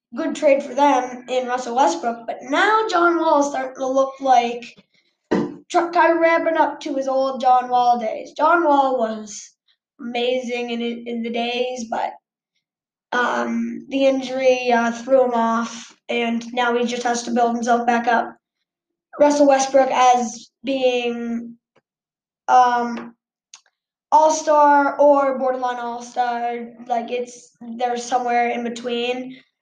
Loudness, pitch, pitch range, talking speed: -19 LUFS, 250 Hz, 235-275 Hz, 135 wpm